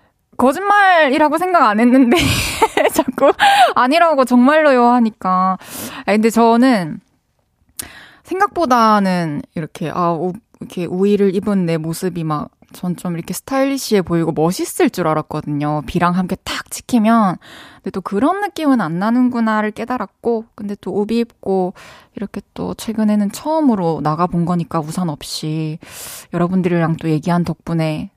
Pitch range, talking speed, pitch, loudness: 175-255 Hz, 305 characters per minute, 205 Hz, -16 LUFS